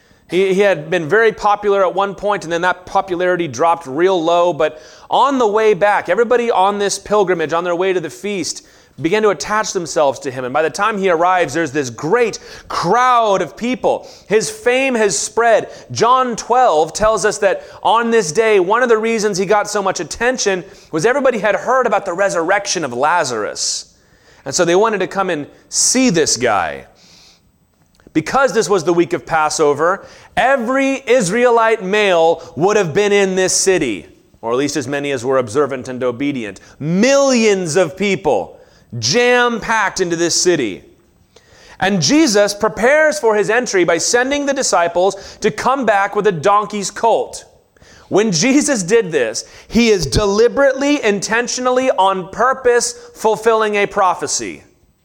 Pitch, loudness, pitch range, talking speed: 205 Hz, -15 LUFS, 175-230 Hz, 165 wpm